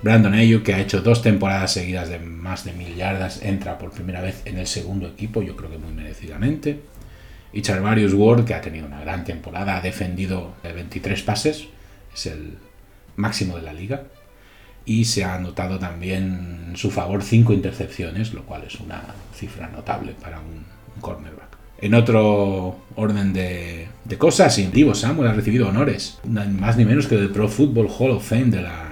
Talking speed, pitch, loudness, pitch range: 180 wpm, 100 Hz, -21 LUFS, 90-110 Hz